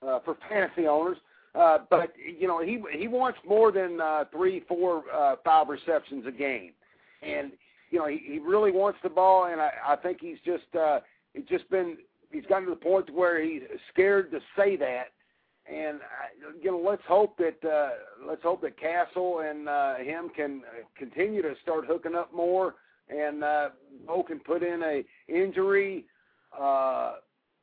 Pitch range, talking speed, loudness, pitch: 155-205 Hz, 180 wpm, -28 LUFS, 175 Hz